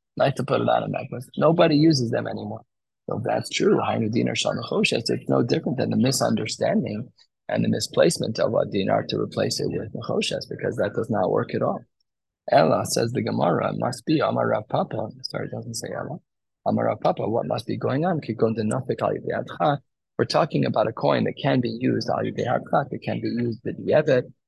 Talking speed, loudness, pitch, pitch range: 180 wpm, -24 LUFS, 120 Hz, 110-140 Hz